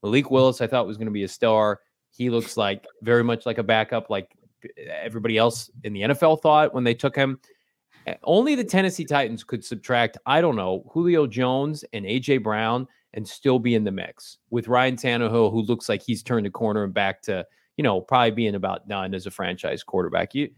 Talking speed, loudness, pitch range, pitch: 215 wpm, -23 LUFS, 110-135 Hz, 120 Hz